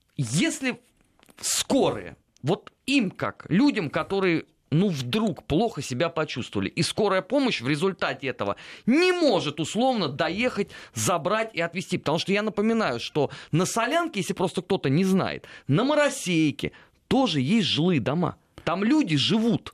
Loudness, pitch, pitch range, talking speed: -25 LUFS, 190 Hz, 155-230 Hz, 140 wpm